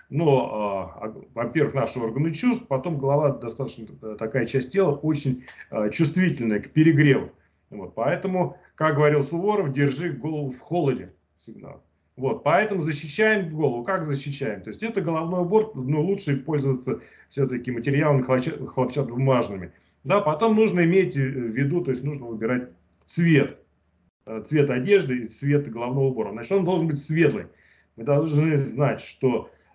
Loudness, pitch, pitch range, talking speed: -24 LUFS, 140 Hz, 125-160 Hz, 140 wpm